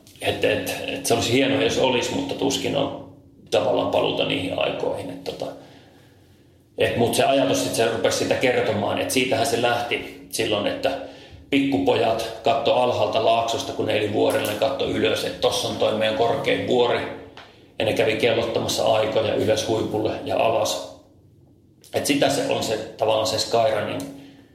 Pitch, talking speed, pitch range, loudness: 115 Hz, 160 wpm, 110-135 Hz, -22 LUFS